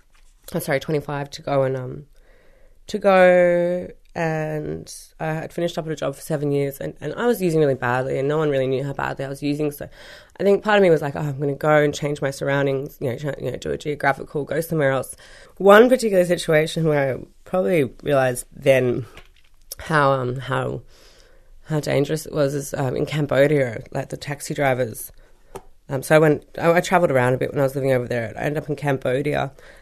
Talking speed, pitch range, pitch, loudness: 220 wpm, 135-165 Hz, 145 Hz, -21 LUFS